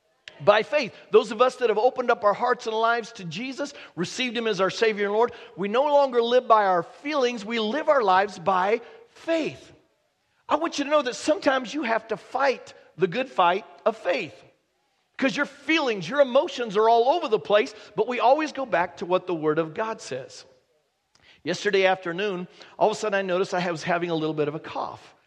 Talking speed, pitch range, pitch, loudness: 215 wpm, 190-265 Hz, 225 Hz, -24 LUFS